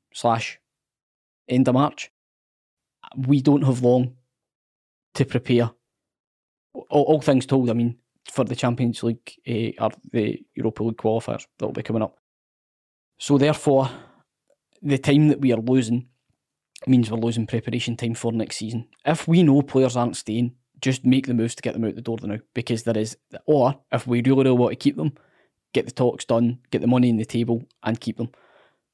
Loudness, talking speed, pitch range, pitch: -22 LUFS, 185 wpm, 115-130 Hz, 120 Hz